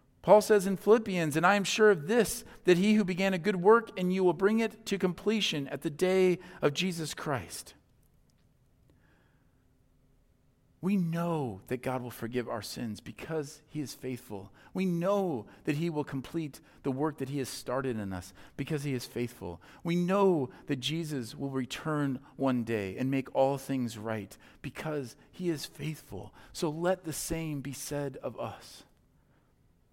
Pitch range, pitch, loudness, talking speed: 130-185 Hz, 150 Hz, -31 LUFS, 170 wpm